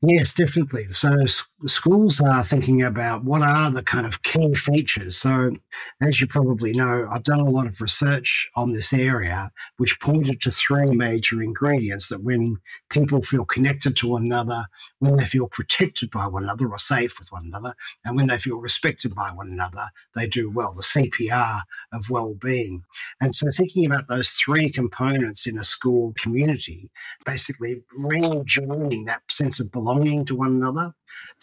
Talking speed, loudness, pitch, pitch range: 170 wpm, -22 LUFS, 125 Hz, 115-140 Hz